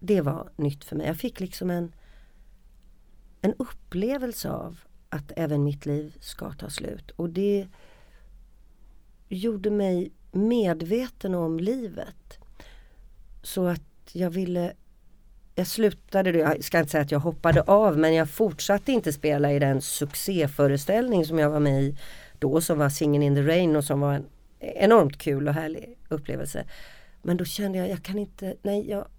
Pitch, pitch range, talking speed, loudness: 165 Hz, 145-195 Hz, 160 wpm, -25 LUFS